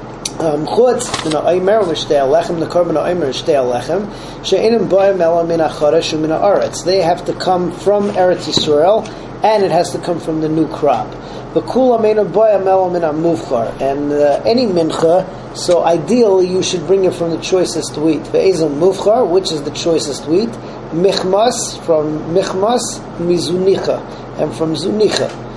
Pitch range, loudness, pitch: 160-190 Hz, -14 LUFS, 175 Hz